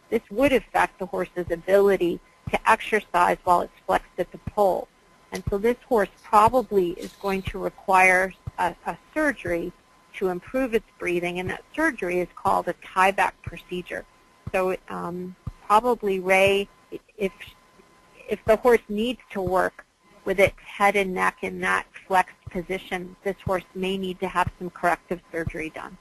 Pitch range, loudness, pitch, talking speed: 180-205 Hz, -24 LUFS, 190 Hz, 160 wpm